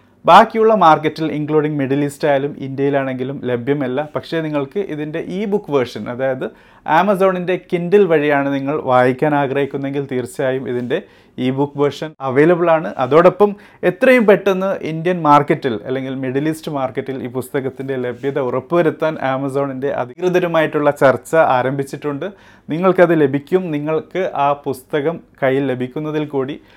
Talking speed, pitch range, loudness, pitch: 120 wpm, 135-165 Hz, -17 LUFS, 145 Hz